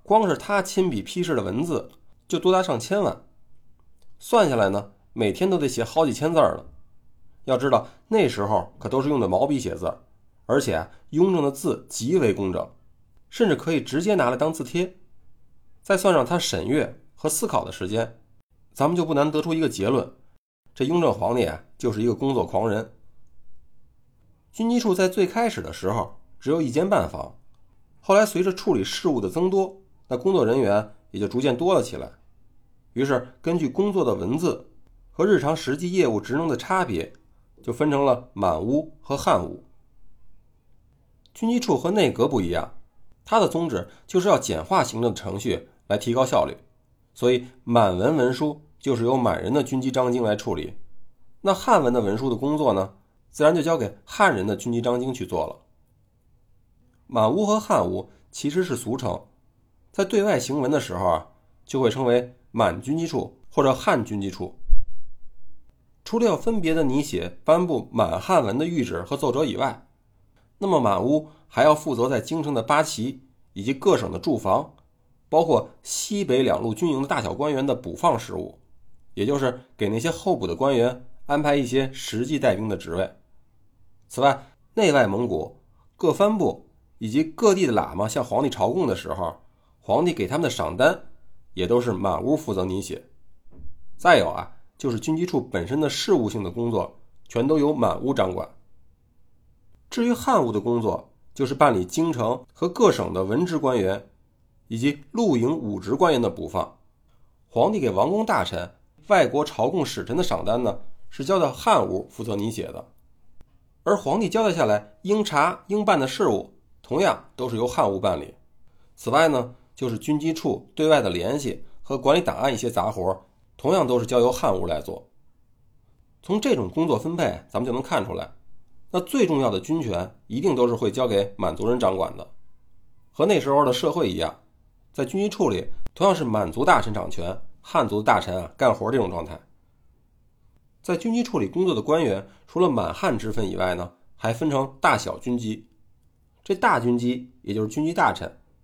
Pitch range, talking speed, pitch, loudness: 110-160 Hz, 260 characters per minute, 130 Hz, -23 LUFS